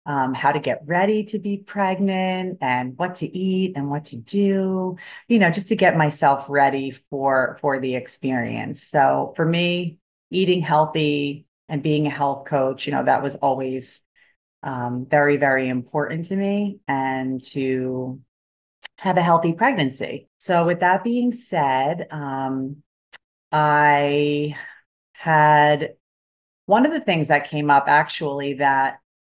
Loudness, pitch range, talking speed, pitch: -21 LUFS, 135-180 Hz, 145 wpm, 145 Hz